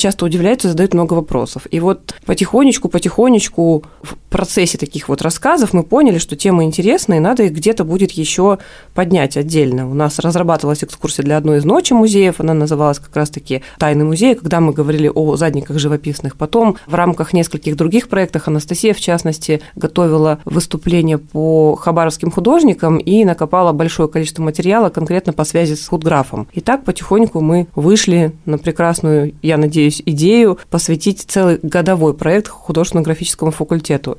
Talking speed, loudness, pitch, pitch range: 155 wpm, -14 LUFS, 165 Hz, 155-185 Hz